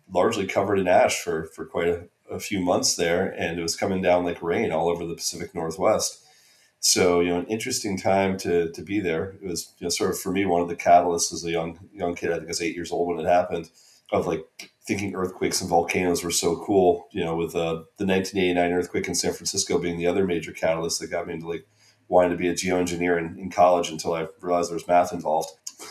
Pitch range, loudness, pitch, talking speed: 85-90 Hz, -24 LUFS, 85 Hz, 245 wpm